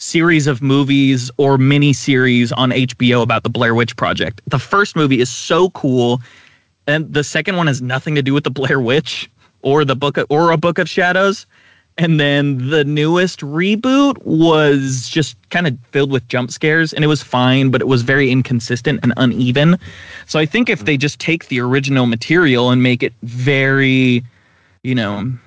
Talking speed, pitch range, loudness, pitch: 190 wpm, 125-155 Hz, -15 LUFS, 135 Hz